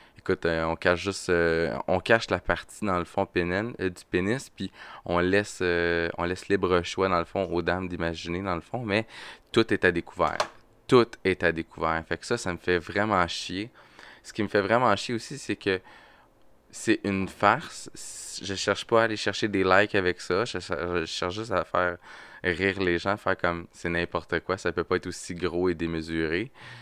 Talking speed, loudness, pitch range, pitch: 215 wpm, -27 LUFS, 85-100 Hz, 90 Hz